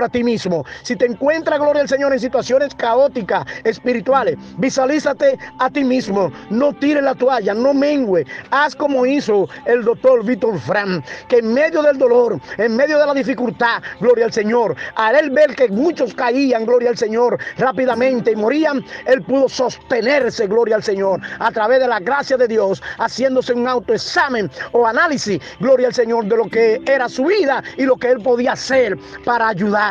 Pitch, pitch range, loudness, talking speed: 255 Hz, 230-275 Hz, -16 LUFS, 180 wpm